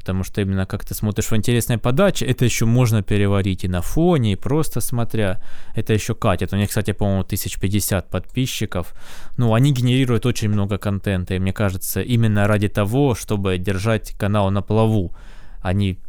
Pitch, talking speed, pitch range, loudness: 105 Hz, 170 wpm, 95-115 Hz, -20 LUFS